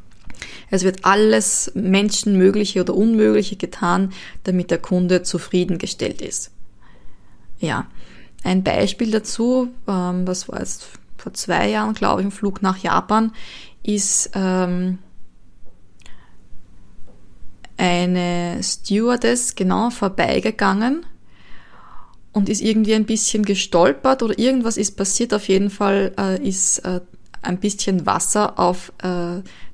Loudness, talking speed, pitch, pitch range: -19 LUFS, 115 wpm, 190 Hz, 180-210 Hz